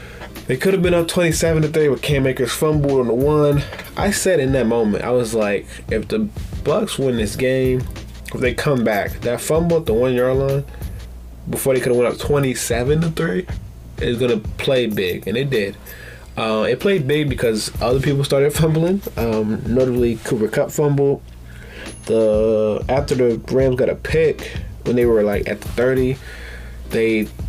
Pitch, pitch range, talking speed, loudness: 125 Hz, 110-145 Hz, 185 wpm, -18 LUFS